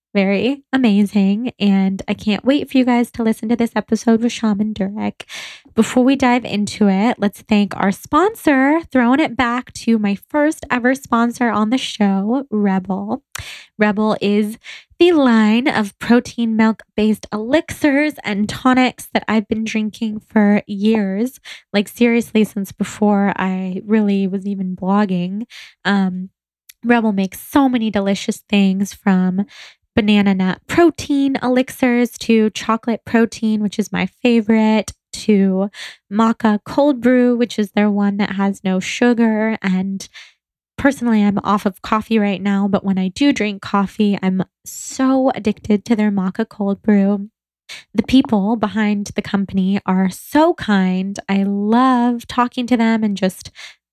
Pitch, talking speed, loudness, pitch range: 215 Hz, 145 wpm, -17 LUFS, 200-240 Hz